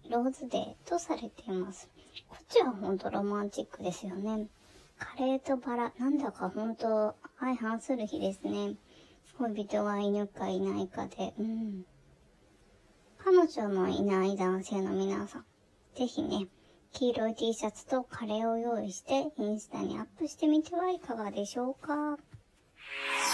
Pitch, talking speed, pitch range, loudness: 225 Hz, 290 characters per minute, 200-265 Hz, -33 LUFS